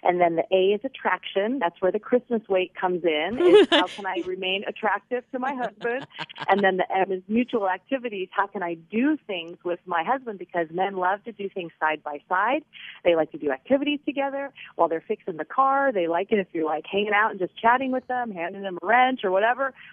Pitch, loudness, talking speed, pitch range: 195 Hz, -24 LUFS, 230 wpm, 180-245 Hz